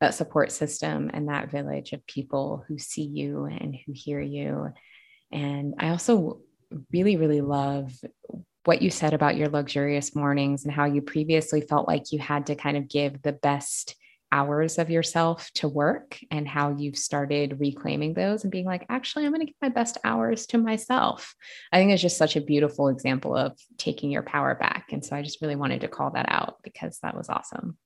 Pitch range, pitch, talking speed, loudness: 140-165 Hz, 145 Hz, 200 wpm, -26 LUFS